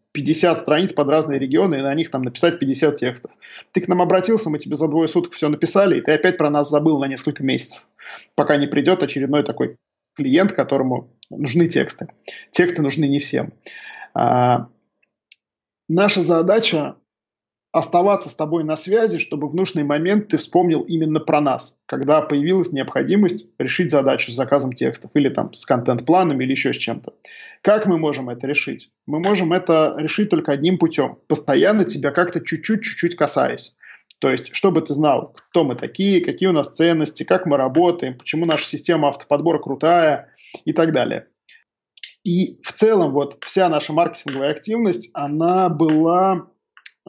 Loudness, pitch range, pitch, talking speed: -19 LUFS, 145-180 Hz, 160 Hz, 165 wpm